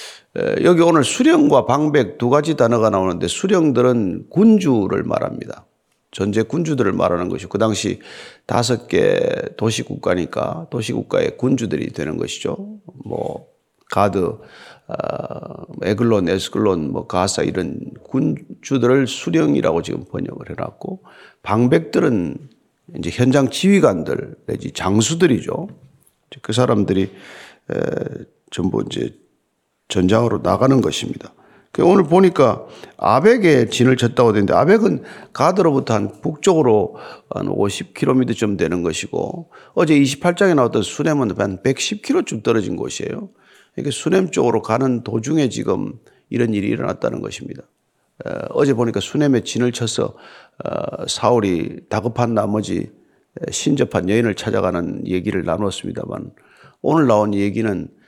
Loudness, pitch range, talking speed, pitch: -18 LUFS, 110-170 Hz, 285 characters per minute, 125 Hz